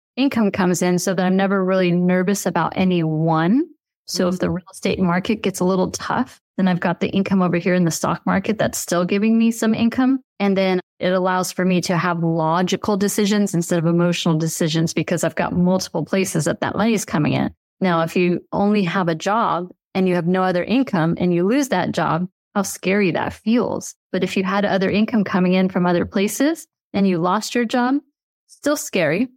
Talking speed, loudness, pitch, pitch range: 215 wpm, -19 LUFS, 185 Hz, 175-205 Hz